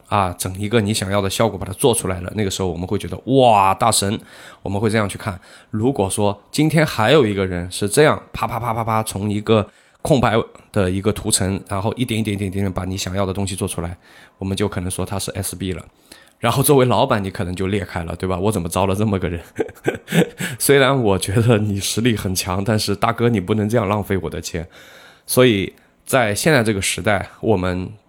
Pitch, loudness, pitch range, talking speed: 100 Hz, -19 LUFS, 95-110 Hz, 325 characters per minute